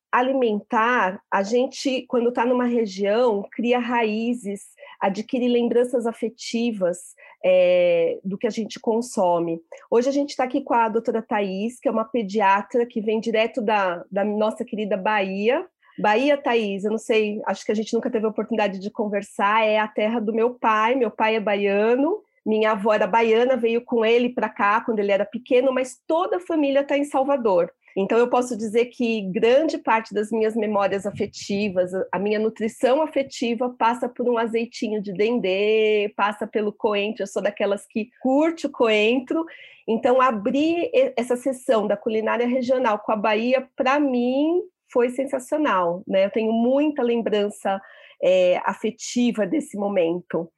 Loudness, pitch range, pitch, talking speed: -22 LUFS, 210-255 Hz, 230 Hz, 165 wpm